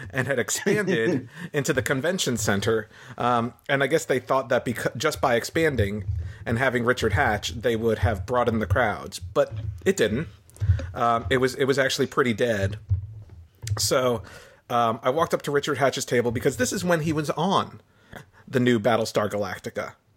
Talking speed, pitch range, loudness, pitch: 175 wpm, 105-135 Hz, -24 LUFS, 120 Hz